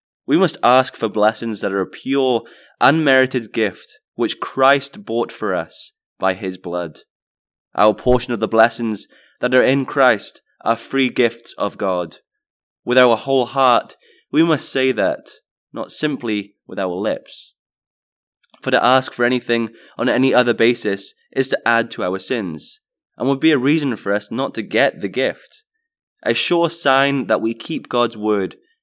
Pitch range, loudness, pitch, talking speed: 110-135 Hz, -18 LUFS, 125 Hz, 170 wpm